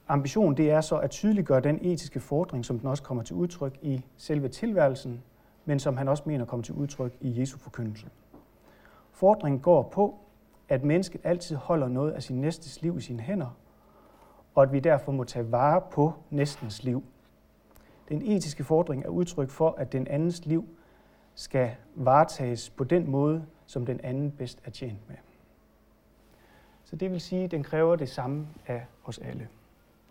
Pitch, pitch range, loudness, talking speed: 140 Hz, 130-160 Hz, -28 LUFS, 175 wpm